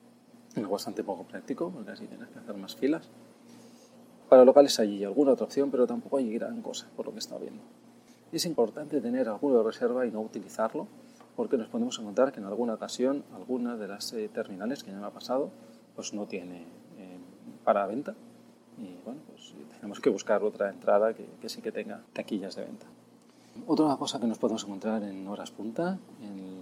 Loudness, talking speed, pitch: -29 LUFS, 185 wpm, 140 Hz